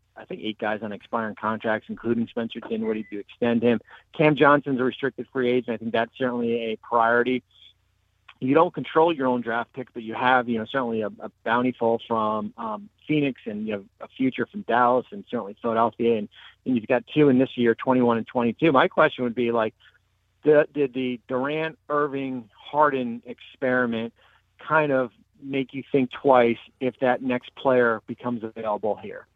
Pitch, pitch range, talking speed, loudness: 120 Hz, 115-130 Hz, 185 wpm, -24 LUFS